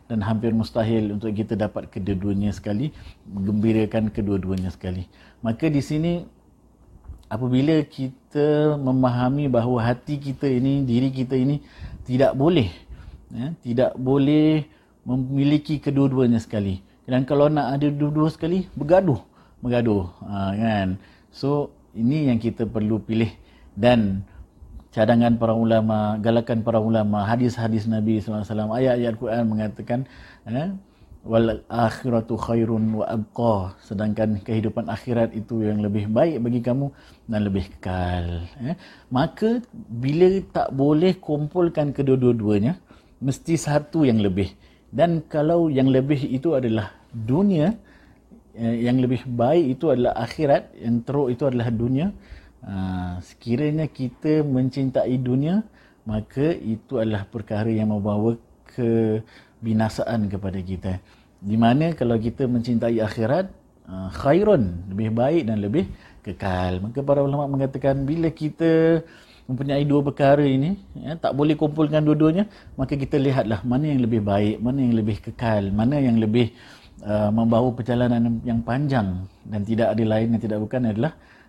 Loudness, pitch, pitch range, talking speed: -22 LUFS, 120 Hz, 110-140 Hz, 125 wpm